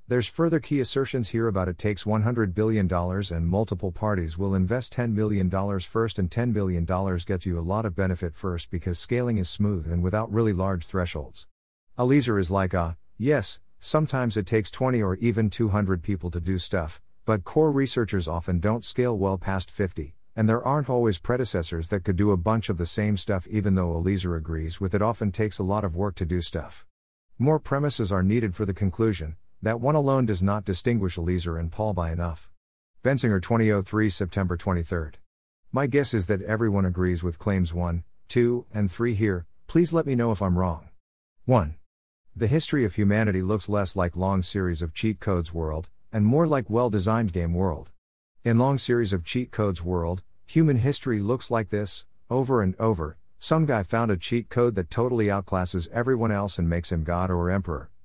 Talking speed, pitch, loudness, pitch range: 190 wpm, 100 Hz, -26 LUFS, 90-115 Hz